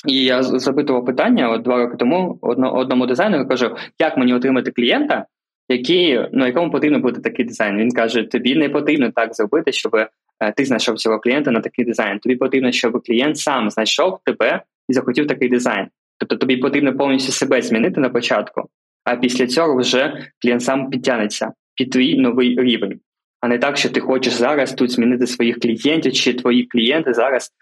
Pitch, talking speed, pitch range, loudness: 125 Hz, 180 wpm, 120-130 Hz, -17 LUFS